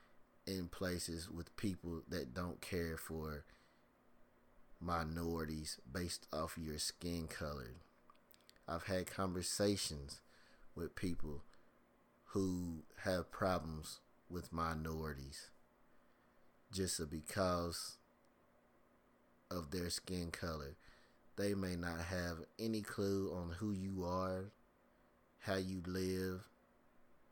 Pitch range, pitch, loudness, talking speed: 80-95 Hz, 85 Hz, -43 LUFS, 95 wpm